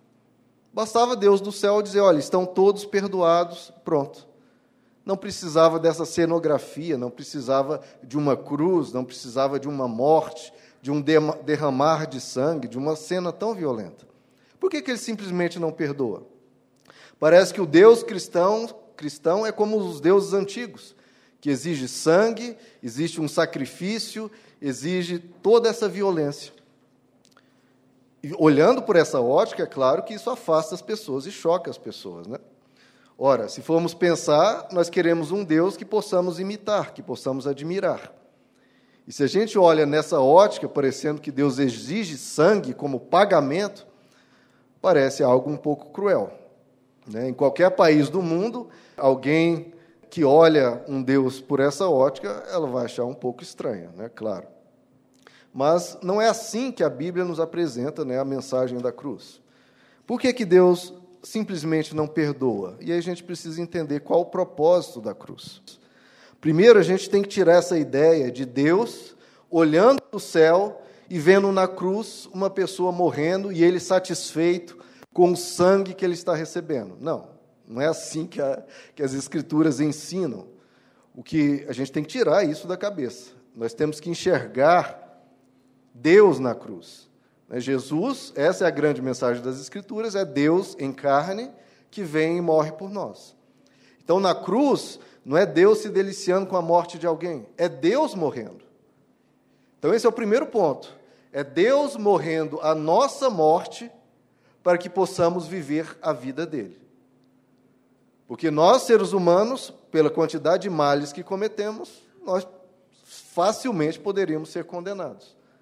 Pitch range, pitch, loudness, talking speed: 145-195 Hz, 170 Hz, -22 LUFS, 150 wpm